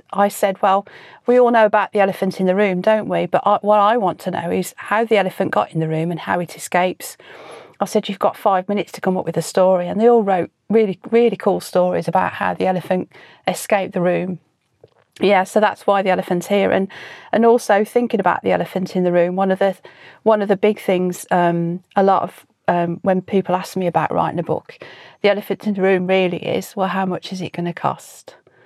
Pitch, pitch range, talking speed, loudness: 190 Hz, 180-205 Hz, 235 wpm, -18 LUFS